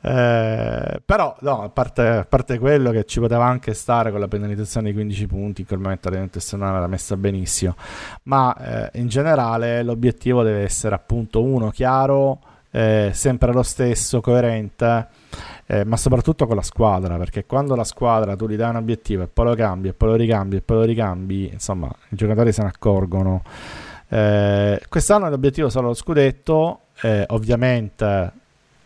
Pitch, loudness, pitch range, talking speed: 110 Hz, -20 LUFS, 100-125 Hz, 175 wpm